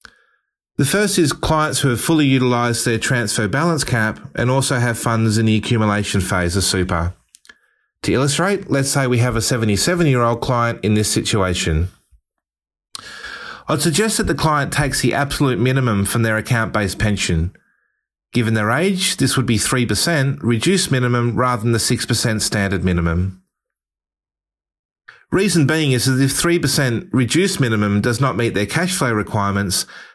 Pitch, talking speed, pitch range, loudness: 120 Hz, 160 wpm, 105-140 Hz, -17 LUFS